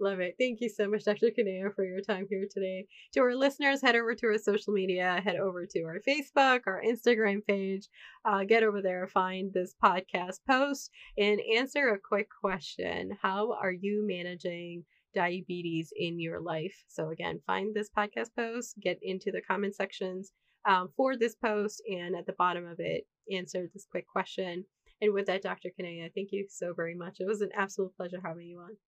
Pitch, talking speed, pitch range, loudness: 195 Hz, 195 wpm, 185-220 Hz, -31 LUFS